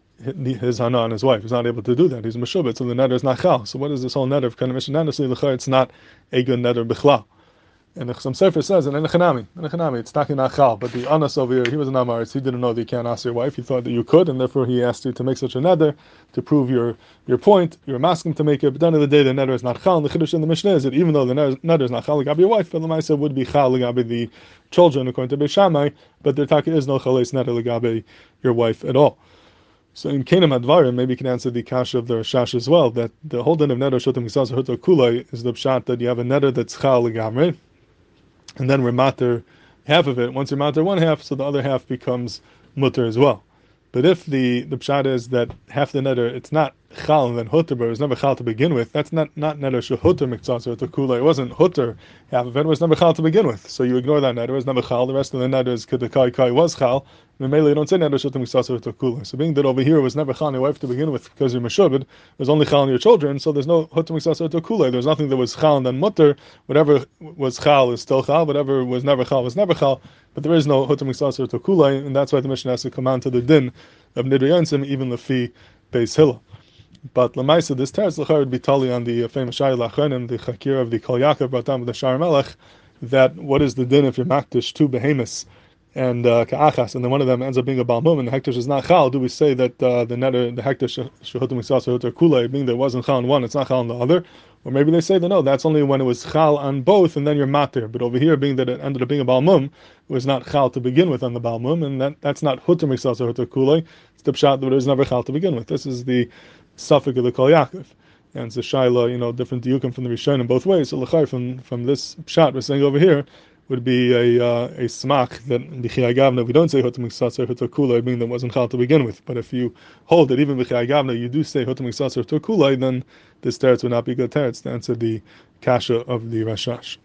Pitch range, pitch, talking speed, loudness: 125-150 Hz, 130 Hz, 255 wpm, -19 LUFS